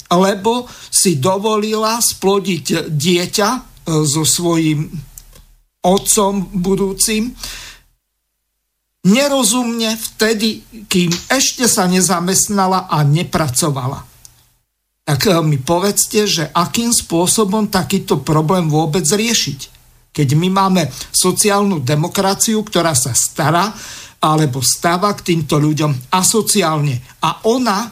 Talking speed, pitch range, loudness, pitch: 90 wpm, 155-210 Hz, -14 LUFS, 185 Hz